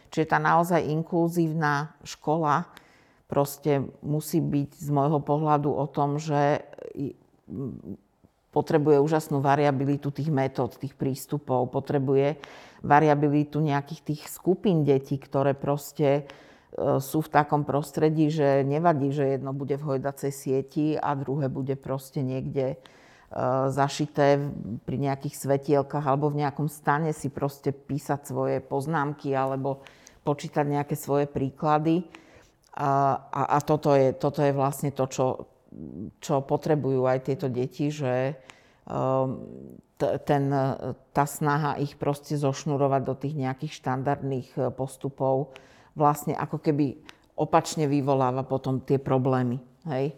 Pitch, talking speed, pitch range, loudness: 140 Hz, 120 wpm, 135-150 Hz, -26 LUFS